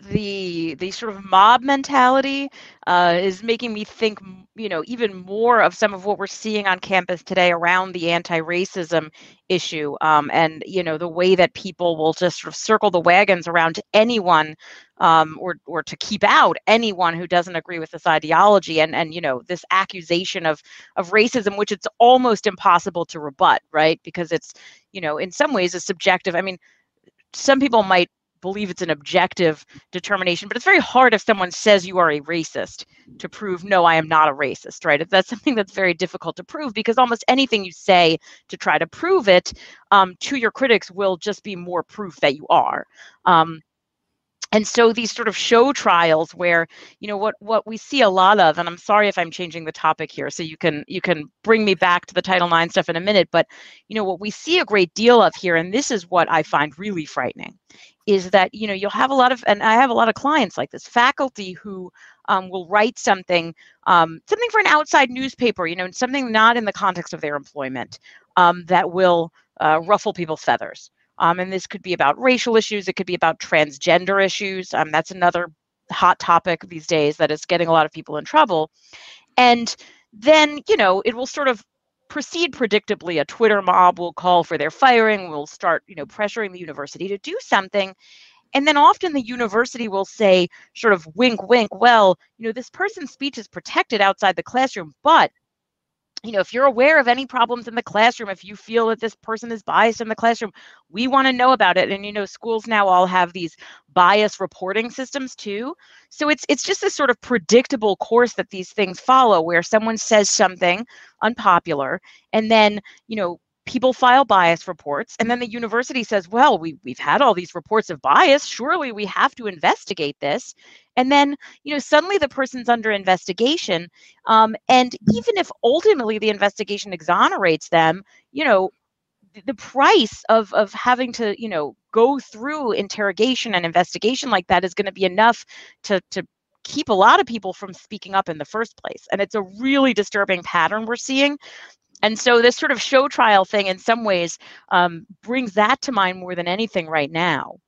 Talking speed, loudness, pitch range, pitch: 205 wpm, -18 LUFS, 175-235 Hz, 200 Hz